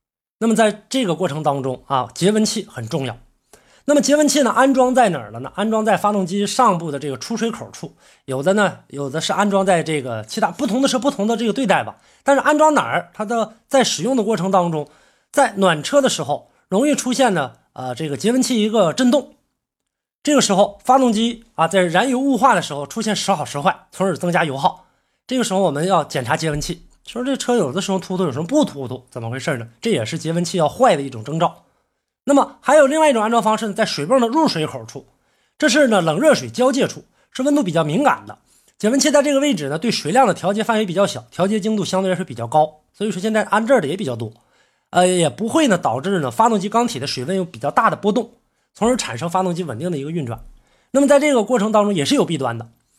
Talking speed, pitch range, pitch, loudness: 355 characters per minute, 155-245 Hz, 195 Hz, -18 LUFS